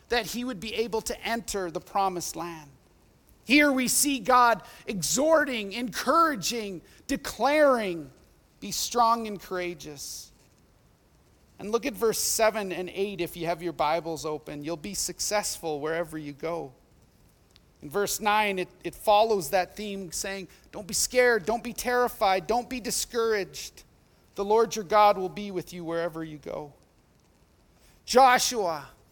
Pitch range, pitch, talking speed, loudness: 175-235 Hz, 205 Hz, 145 wpm, -26 LUFS